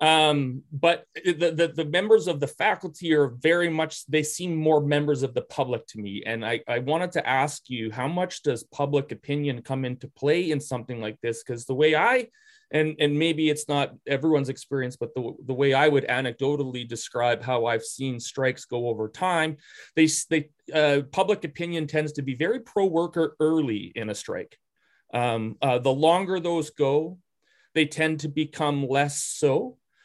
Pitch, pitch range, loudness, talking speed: 150 Hz, 130-160 Hz, -25 LUFS, 185 wpm